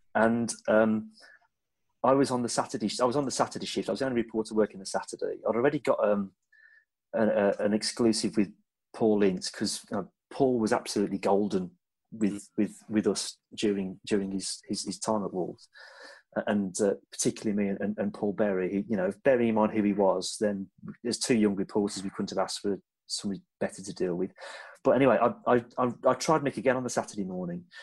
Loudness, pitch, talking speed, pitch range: -29 LUFS, 110 Hz, 200 wpm, 100-125 Hz